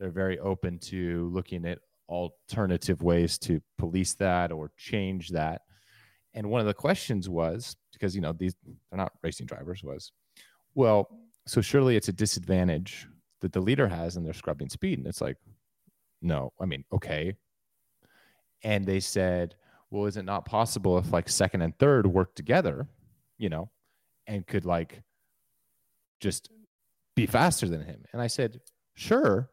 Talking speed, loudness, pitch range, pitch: 160 wpm, -29 LUFS, 90-110 Hz, 95 Hz